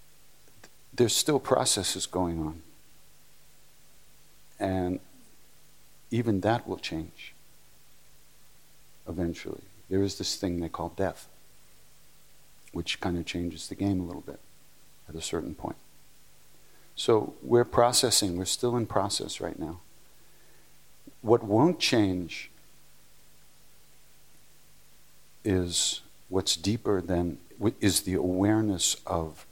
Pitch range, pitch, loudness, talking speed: 85-105 Hz, 95 Hz, -28 LUFS, 105 wpm